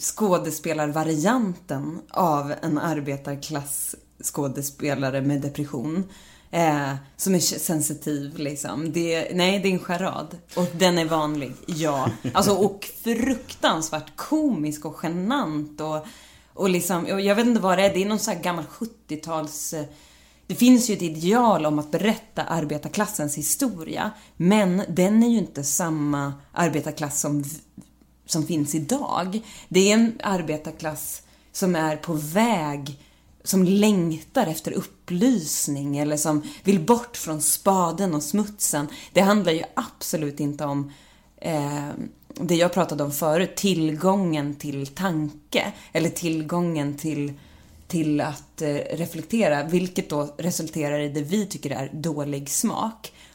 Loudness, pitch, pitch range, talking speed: -24 LUFS, 160 Hz, 150-190 Hz, 135 wpm